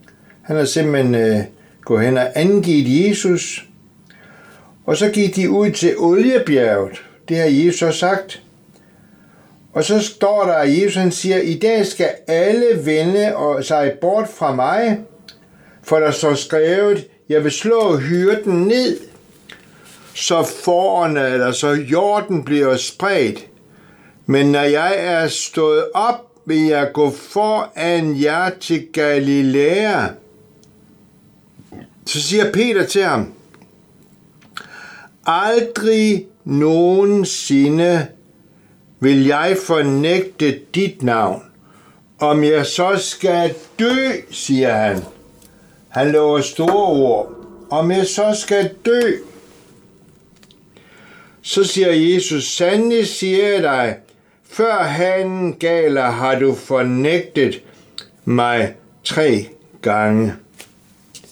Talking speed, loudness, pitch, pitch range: 110 wpm, -16 LUFS, 175 Hz, 145-200 Hz